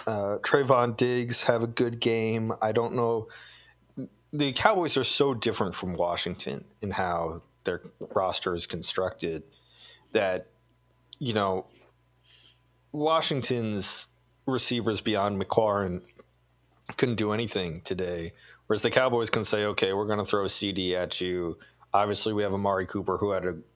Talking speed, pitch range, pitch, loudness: 140 wpm, 95-120 Hz, 110 Hz, -28 LUFS